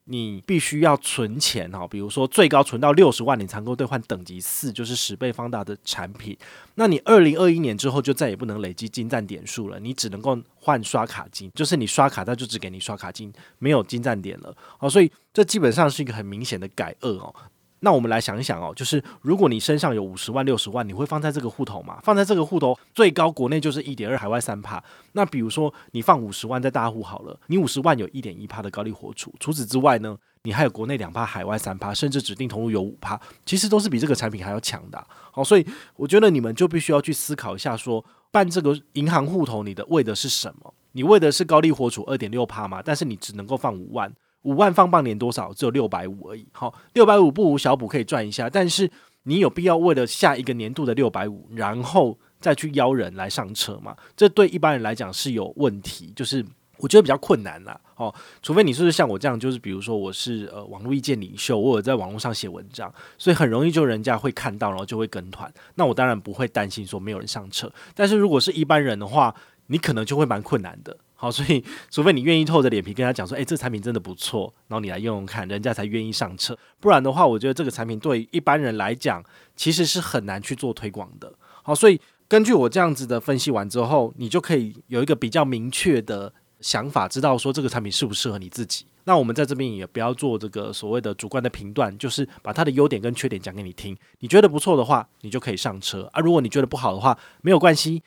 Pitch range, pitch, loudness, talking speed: 110-150 Hz, 125 Hz, -22 LUFS, 365 characters per minute